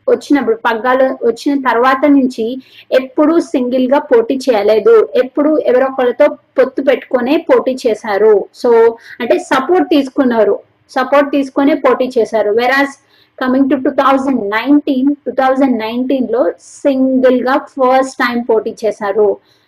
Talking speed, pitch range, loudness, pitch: 120 wpm, 245-290 Hz, -12 LUFS, 265 Hz